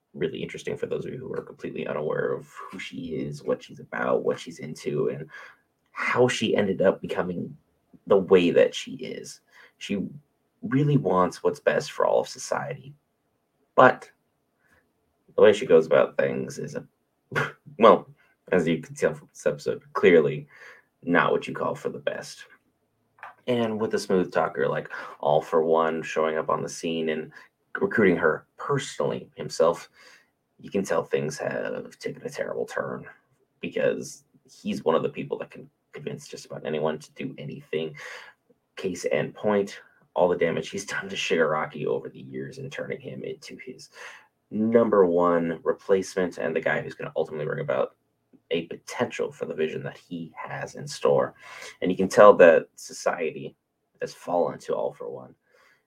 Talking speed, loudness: 170 wpm, -25 LUFS